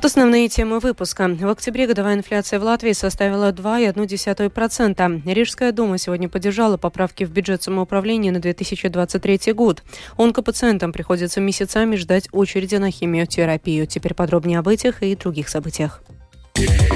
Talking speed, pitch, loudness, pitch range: 130 wpm, 195 Hz, -19 LUFS, 180-220 Hz